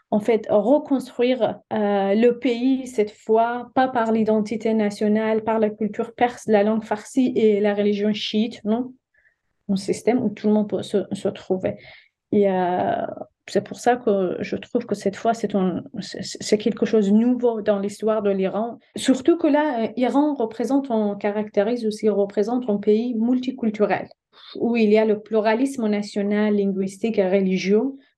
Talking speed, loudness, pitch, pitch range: 175 wpm, -22 LUFS, 215 Hz, 205-240 Hz